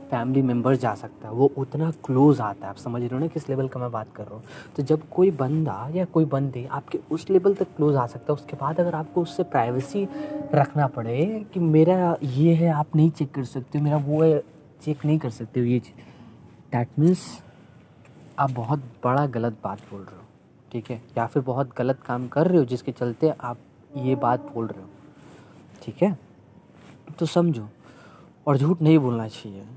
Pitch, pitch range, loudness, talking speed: 140 Hz, 120-155 Hz, -24 LUFS, 210 wpm